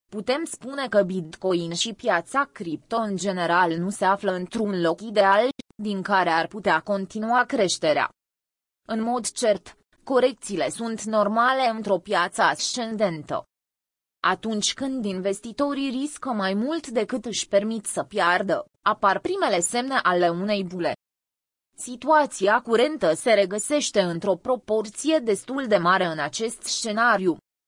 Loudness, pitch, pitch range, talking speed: -24 LUFS, 215 Hz, 190-245 Hz, 130 wpm